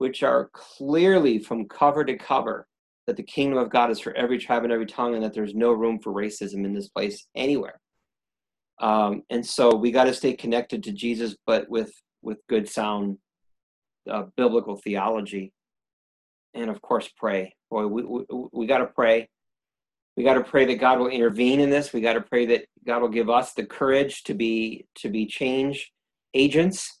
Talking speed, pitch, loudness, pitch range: 190 wpm, 120 Hz, -24 LUFS, 110-130 Hz